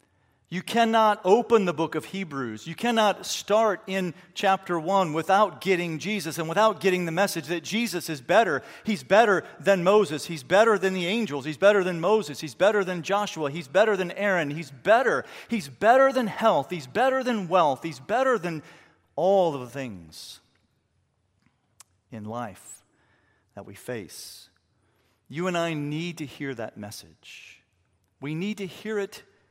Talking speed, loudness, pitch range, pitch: 165 wpm, -24 LUFS, 135-200 Hz, 175 Hz